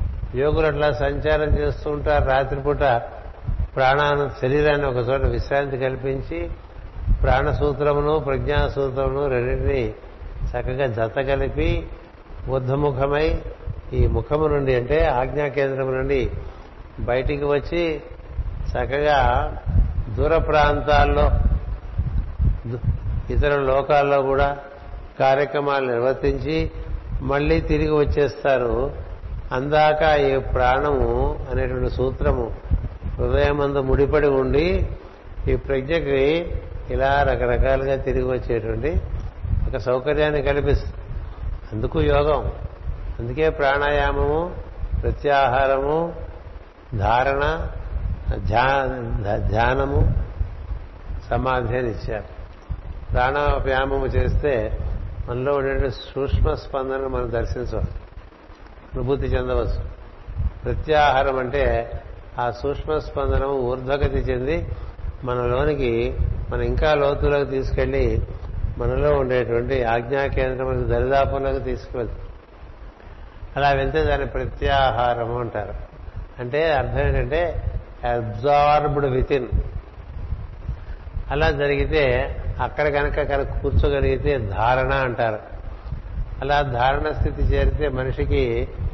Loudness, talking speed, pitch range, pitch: -22 LUFS, 80 wpm, 100-140 Hz, 130 Hz